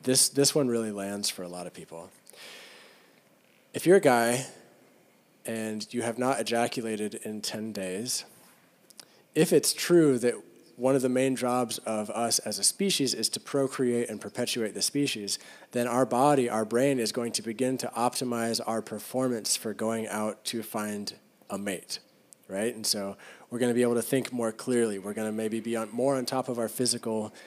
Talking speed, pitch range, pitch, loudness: 185 wpm, 110-130 Hz, 120 Hz, -28 LUFS